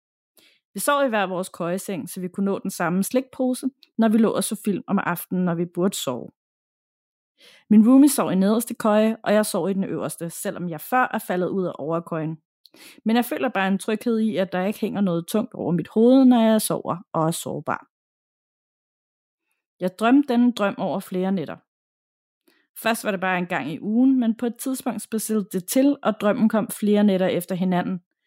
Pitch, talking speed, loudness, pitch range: 205 Hz, 205 wpm, -22 LUFS, 185-230 Hz